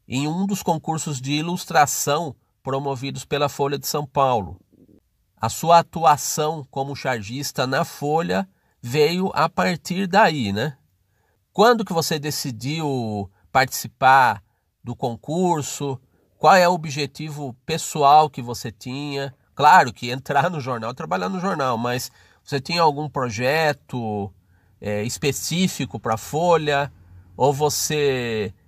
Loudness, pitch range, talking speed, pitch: -21 LUFS, 120-155 Hz, 125 wpm, 140 Hz